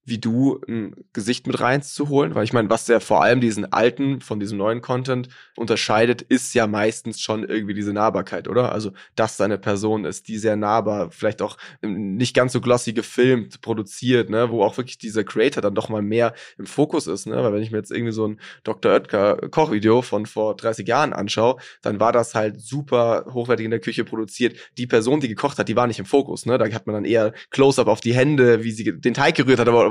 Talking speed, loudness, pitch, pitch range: 225 wpm, -21 LUFS, 115 Hz, 110-125 Hz